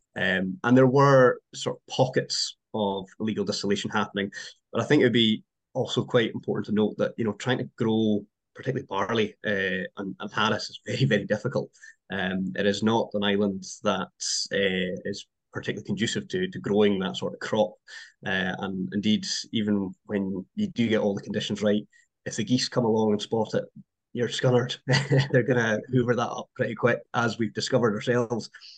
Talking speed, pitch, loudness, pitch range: 185 wpm, 110 Hz, -26 LUFS, 100-125 Hz